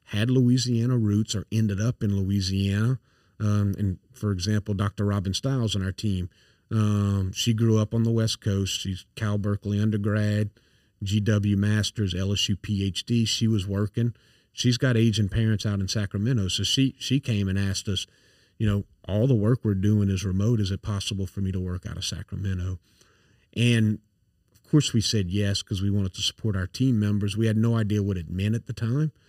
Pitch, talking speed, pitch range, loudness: 105 Hz, 195 wpm, 100-115 Hz, -25 LUFS